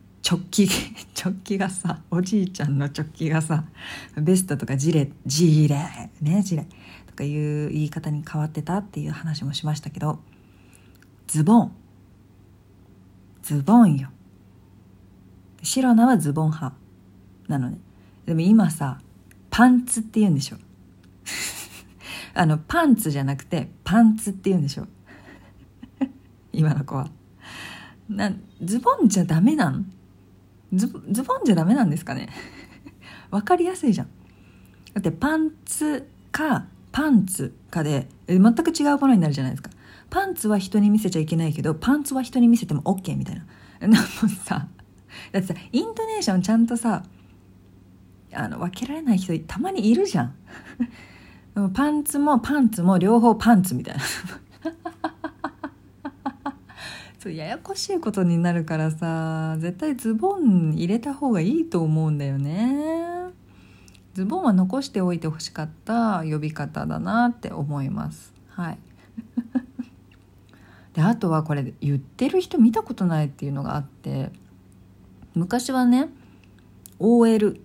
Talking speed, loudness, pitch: 275 characters per minute, -23 LUFS, 165 Hz